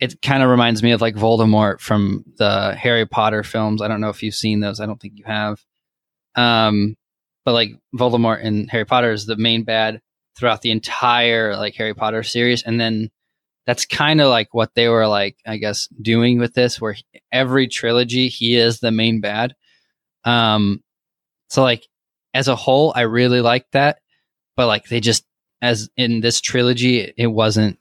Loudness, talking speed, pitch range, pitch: -17 LUFS, 190 wpm, 110-120 Hz, 115 Hz